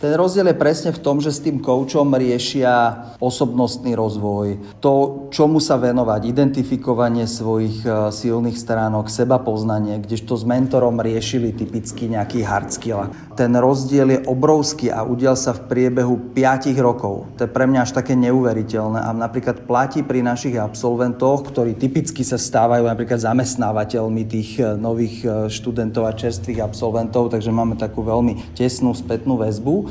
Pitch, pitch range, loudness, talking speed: 120 Hz, 115-130 Hz, -19 LUFS, 150 wpm